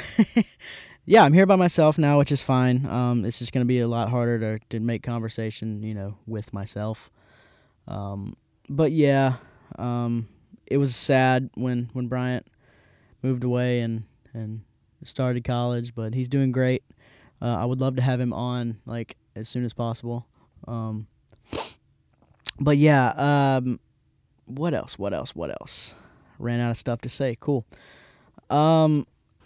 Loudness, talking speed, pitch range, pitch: -24 LUFS, 155 wpm, 115-130 Hz, 120 Hz